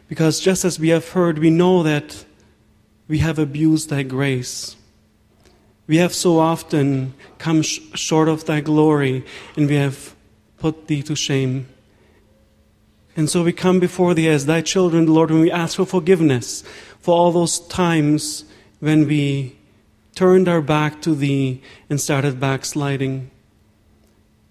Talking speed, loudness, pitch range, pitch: 145 wpm, -18 LUFS, 130-165 Hz, 150 Hz